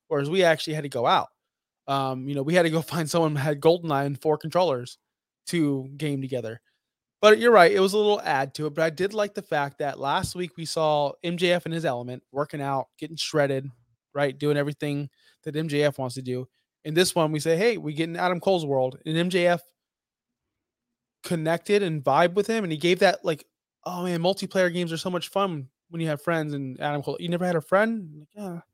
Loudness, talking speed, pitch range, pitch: -25 LUFS, 225 wpm, 140-175 Hz, 160 Hz